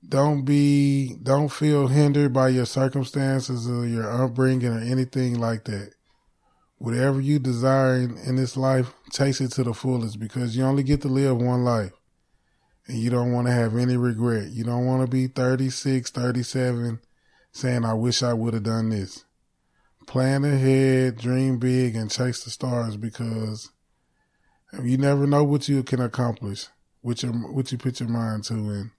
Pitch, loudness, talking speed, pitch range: 125 Hz, -23 LUFS, 170 wpm, 115-135 Hz